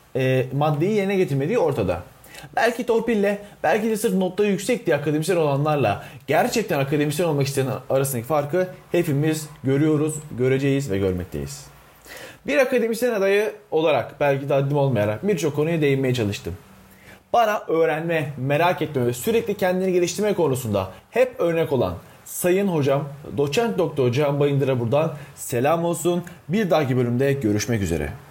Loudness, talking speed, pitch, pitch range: -22 LUFS, 135 wpm, 150 Hz, 135-185 Hz